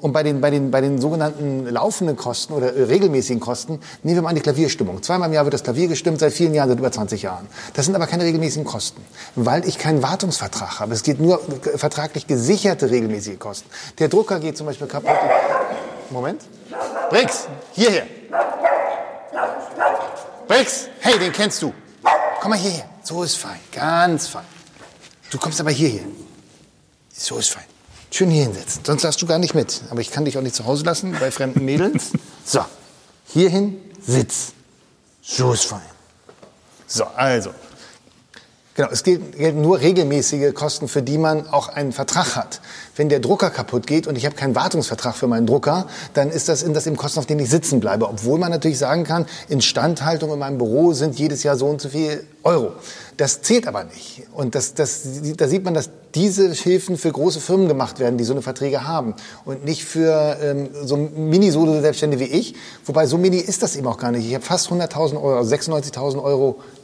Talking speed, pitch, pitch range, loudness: 190 wpm, 150 Hz, 135-170 Hz, -19 LUFS